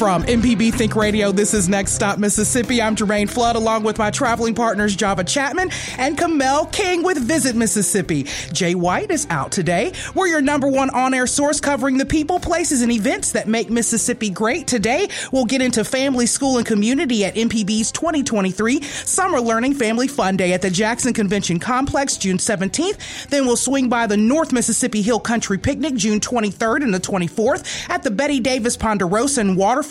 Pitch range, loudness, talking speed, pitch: 210-270 Hz, -18 LUFS, 185 wpm, 235 Hz